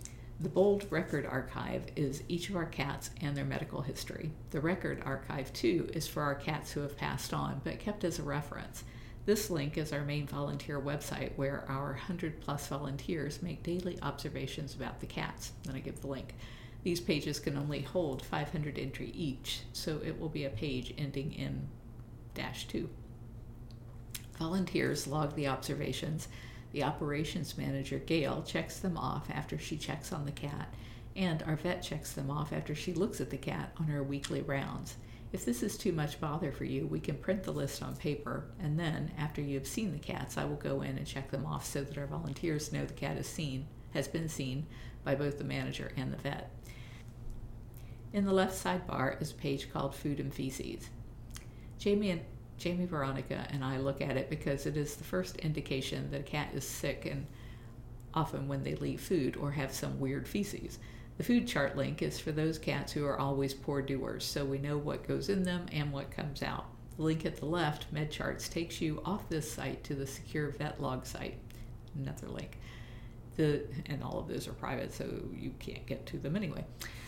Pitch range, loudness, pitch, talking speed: 120-155 Hz, -37 LUFS, 140 Hz, 195 wpm